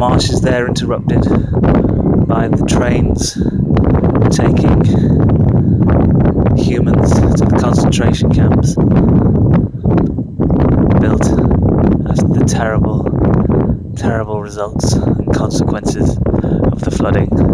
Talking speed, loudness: 80 wpm, -12 LUFS